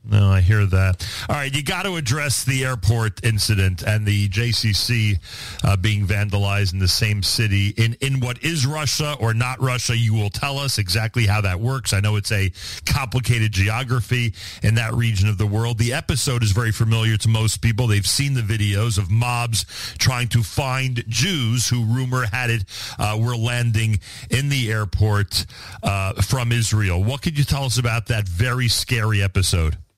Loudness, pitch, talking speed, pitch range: -20 LUFS, 110 Hz, 185 wpm, 100-125 Hz